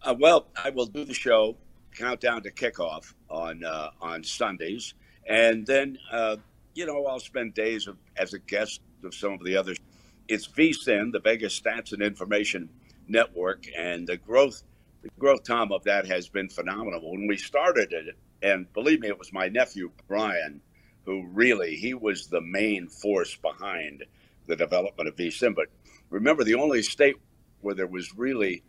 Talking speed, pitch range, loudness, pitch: 175 wpm, 95-115 Hz, -27 LUFS, 105 Hz